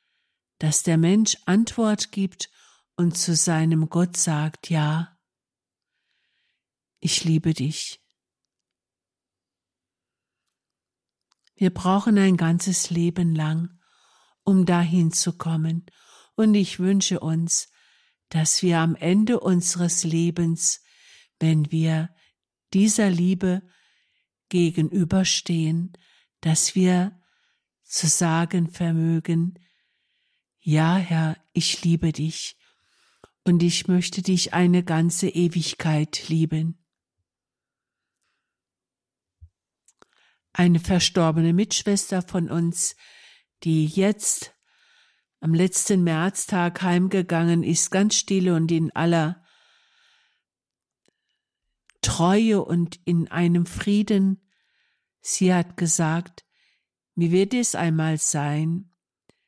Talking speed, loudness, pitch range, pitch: 90 wpm, -22 LUFS, 160-190 Hz, 175 Hz